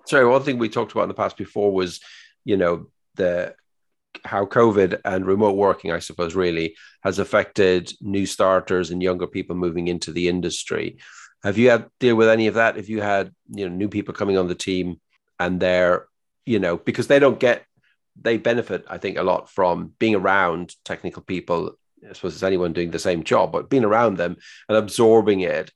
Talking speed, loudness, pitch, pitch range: 200 wpm, -21 LUFS, 95 Hz, 90-110 Hz